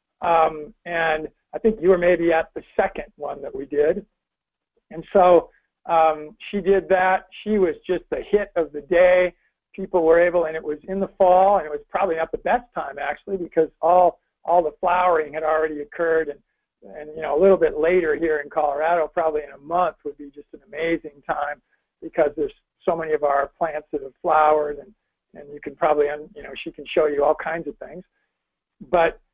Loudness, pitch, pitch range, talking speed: -21 LUFS, 165 Hz, 150-185 Hz, 210 wpm